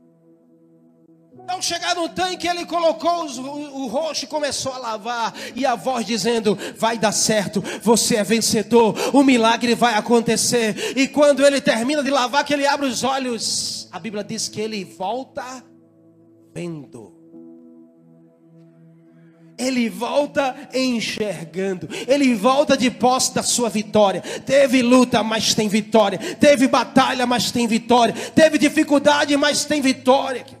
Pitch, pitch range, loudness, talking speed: 235 Hz, 200-275 Hz, -19 LUFS, 140 wpm